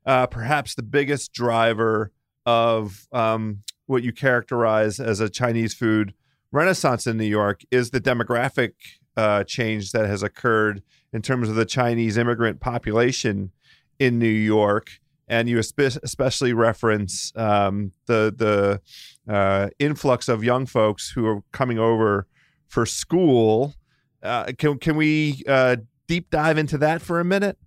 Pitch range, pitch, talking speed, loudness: 110-130 Hz, 115 Hz, 145 wpm, -22 LUFS